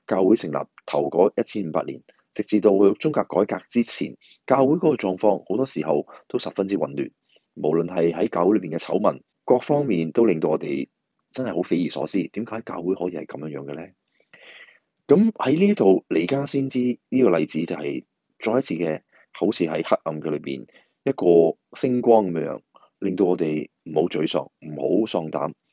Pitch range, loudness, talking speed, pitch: 85-135 Hz, -23 LUFS, 280 characters per minute, 105 Hz